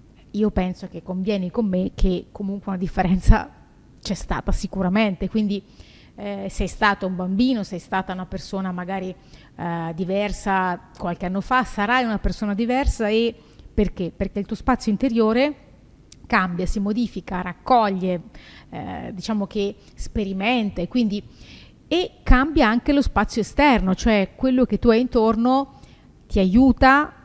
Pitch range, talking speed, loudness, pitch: 190-230 Hz, 140 wpm, -22 LUFS, 205 Hz